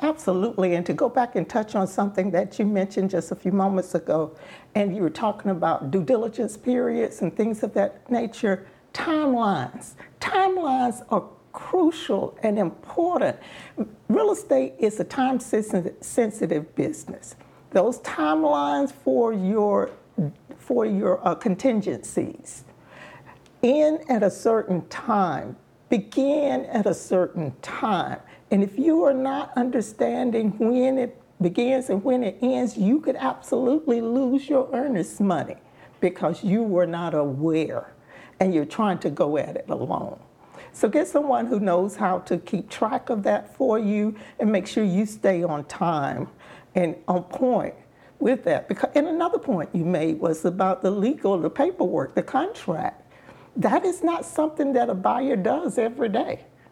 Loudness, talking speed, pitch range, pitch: -24 LUFS, 150 wpm, 185-255 Hz, 220 Hz